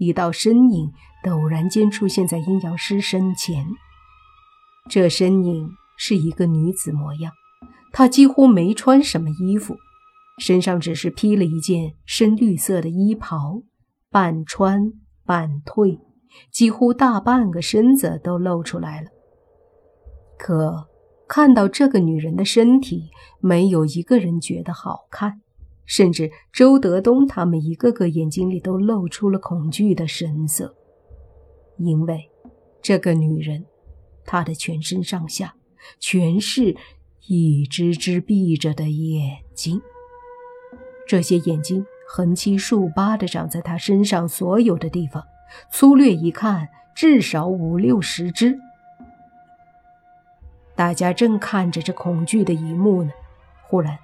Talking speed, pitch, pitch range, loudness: 190 characters per minute, 185 Hz, 165-240 Hz, -19 LUFS